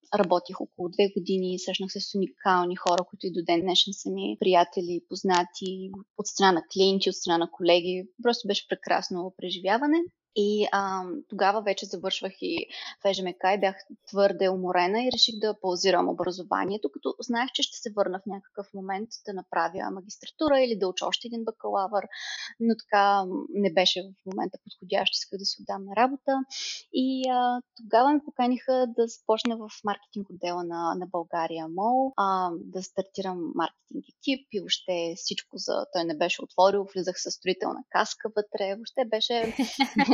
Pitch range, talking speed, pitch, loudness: 185-230 Hz, 165 wpm, 195 Hz, -27 LUFS